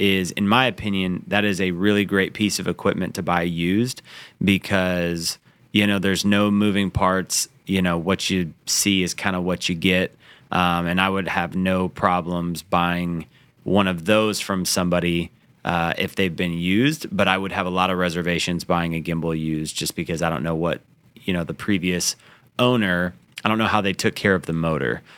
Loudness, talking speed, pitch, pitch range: -22 LUFS, 200 wpm, 95 Hz, 85-100 Hz